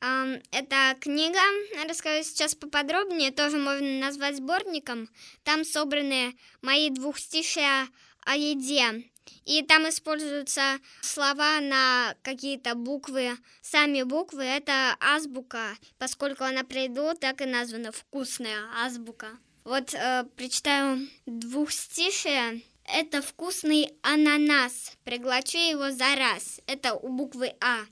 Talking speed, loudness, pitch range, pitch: 105 wpm, -26 LUFS, 255-295 Hz, 275 Hz